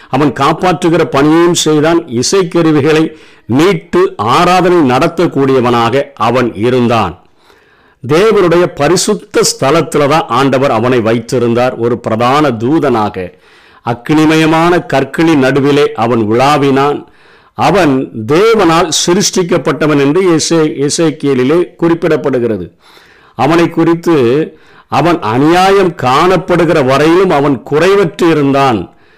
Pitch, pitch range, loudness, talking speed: 150 Hz, 125-170 Hz, -10 LUFS, 80 wpm